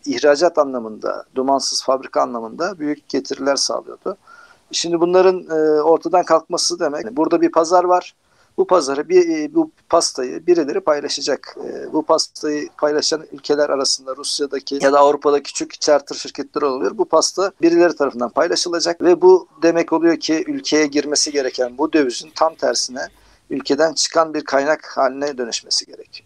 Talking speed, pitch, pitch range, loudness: 140 wpm, 160 Hz, 145-175 Hz, -18 LUFS